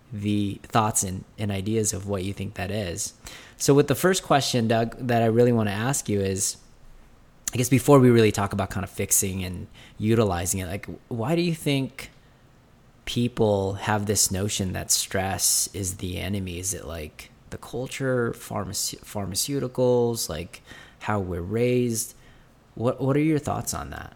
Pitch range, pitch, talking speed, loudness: 100-125 Hz, 110 Hz, 175 wpm, -24 LUFS